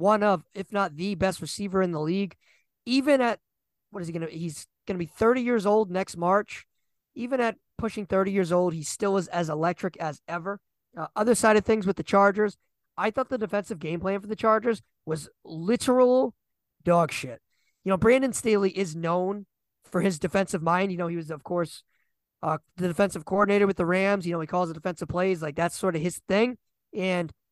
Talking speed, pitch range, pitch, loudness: 205 wpm, 170-210 Hz, 190 Hz, -26 LUFS